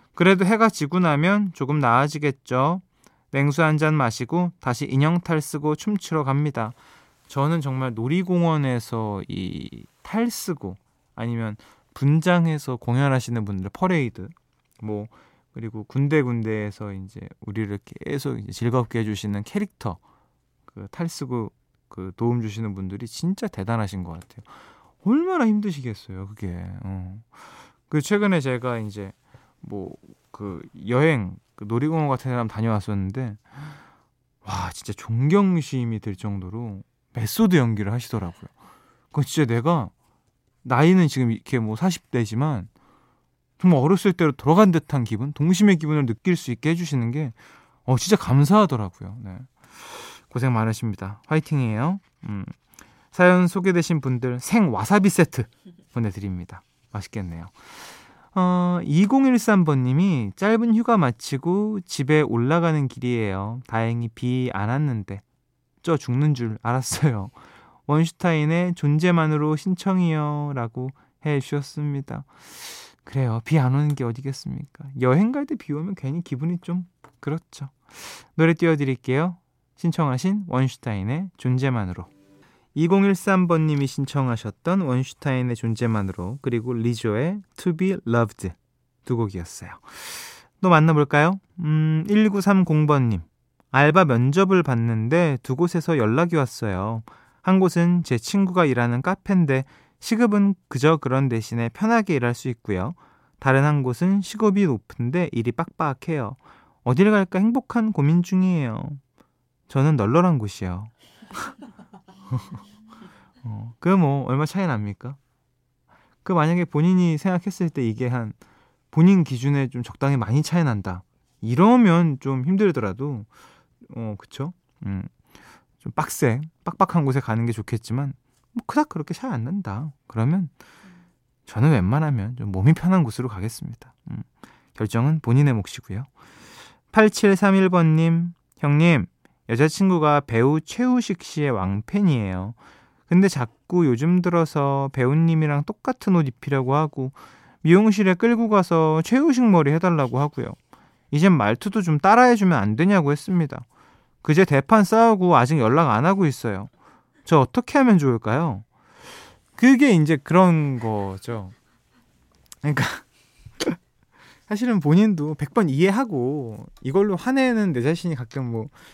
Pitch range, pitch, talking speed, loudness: 120-175 Hz, 145 Hz, 280 characters per minute, -21 LUFS